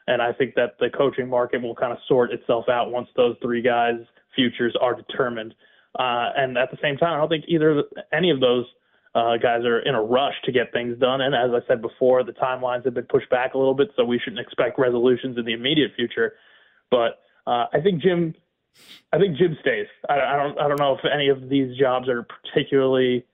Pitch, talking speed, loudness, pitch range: 130 Hz, 225 wpm, -22 LUFS, 120-145 Hz